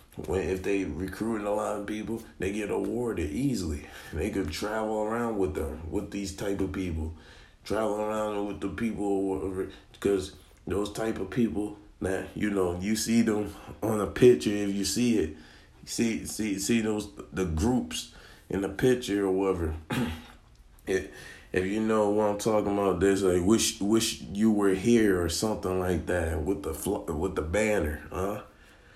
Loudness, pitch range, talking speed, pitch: -29 LUFS, 95-105 Hz, 175 wpm, 100 Hz